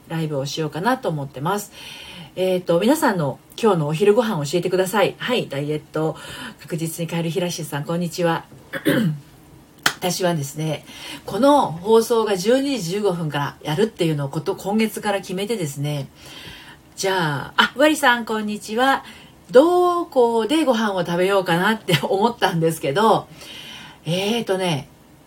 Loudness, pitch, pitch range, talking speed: -20 LUFS, 185 Hz, 160-220 Hz, 325 characters per minute